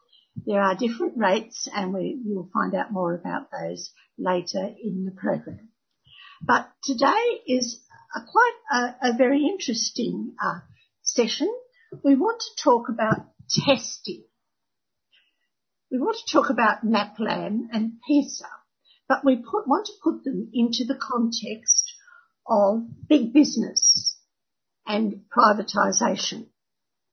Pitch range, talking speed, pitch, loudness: 210-285 Hz, 125 wpm, 245 Hz, -24 LUFS